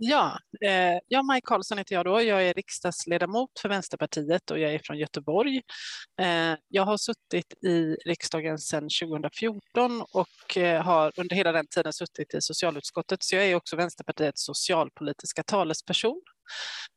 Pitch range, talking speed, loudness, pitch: 160-205 Hz, 140 wpm, -27 LUFS, 175 Hz